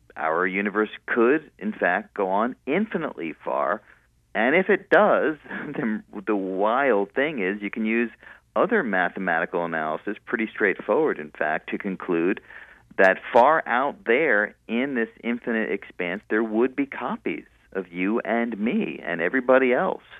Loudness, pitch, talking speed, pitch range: -24 LUFS, 110 Hz, 145 wpm, 95-120 Hz